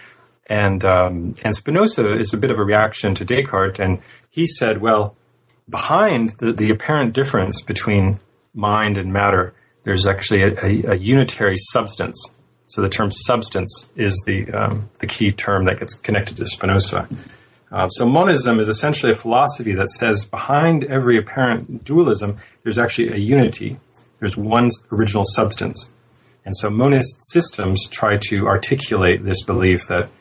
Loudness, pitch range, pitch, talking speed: -16 LUFS, 100-120 Hz, 110 Hz, 155 wpm